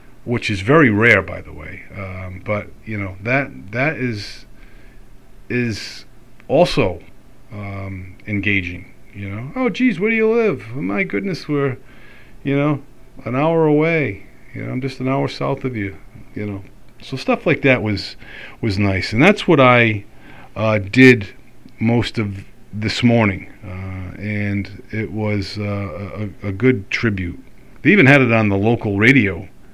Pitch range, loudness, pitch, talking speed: 100-130 Hz, -17 LUFS, 110 Hz, 160 wpm